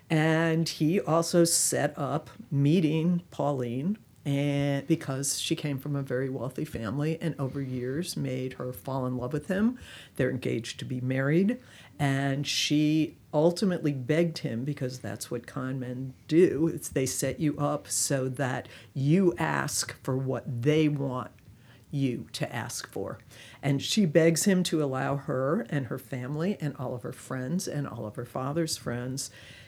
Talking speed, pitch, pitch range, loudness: 160 wpm, 140 Hz, 130-160 Hz, -29 LUFS